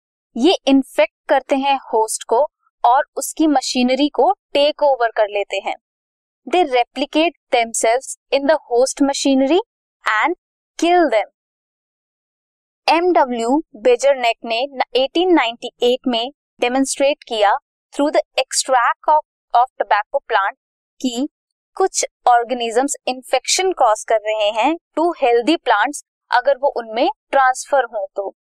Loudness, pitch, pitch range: -17 LUFS, 275 Hz, 240-315 Hz